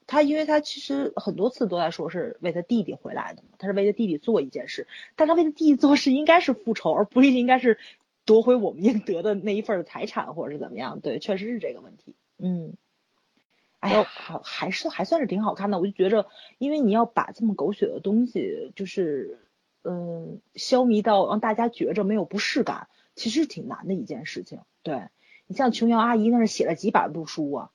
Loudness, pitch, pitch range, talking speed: -24 LUFS, 225 Hz, 200-265 Hz, 315 characters per minute